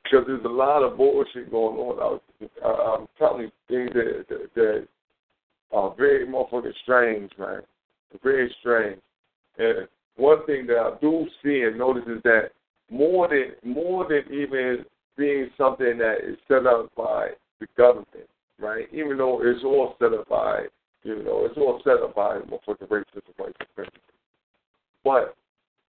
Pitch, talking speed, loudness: 155 Hz, 160 wpm, -23 LUFS